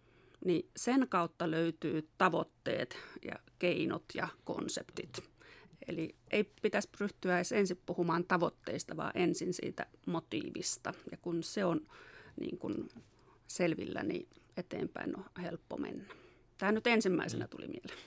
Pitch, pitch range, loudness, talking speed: 180 Hz, 170-210 Hz, -37 LUFS, 125 wpm